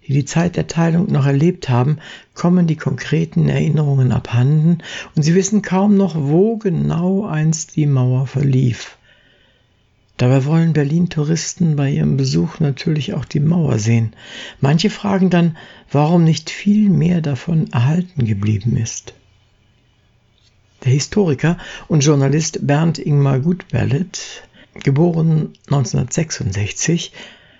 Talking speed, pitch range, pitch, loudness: 115 wpm, 130-170 Hz, 150 Hz, -16 LUFS